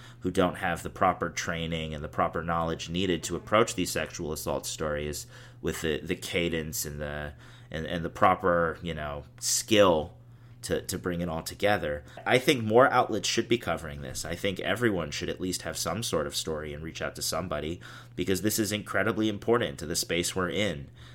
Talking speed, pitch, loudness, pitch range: 200 wpm, 90 Hz, -29 LUFS, 80-110 Hz